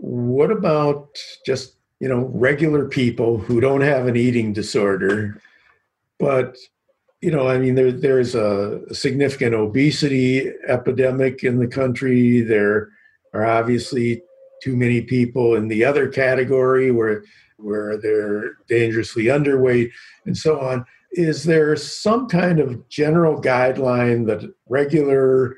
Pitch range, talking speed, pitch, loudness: 115-140 Hz, 130 wpm, 130 Hz, -19 LUFS